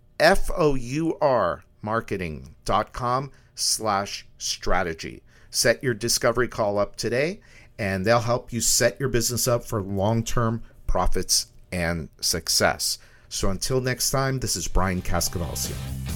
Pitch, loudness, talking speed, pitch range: 115 Hz, -24 LUFS, 115 wpm, 95-120 Hz